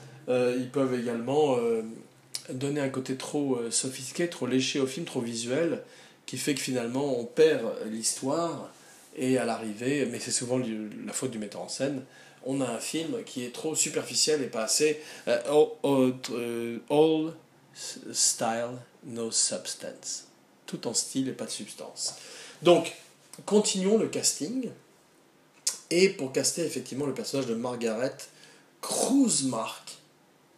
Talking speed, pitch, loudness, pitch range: 135 wpm, 130 Hz, -28 LUFS, 120-155 Hz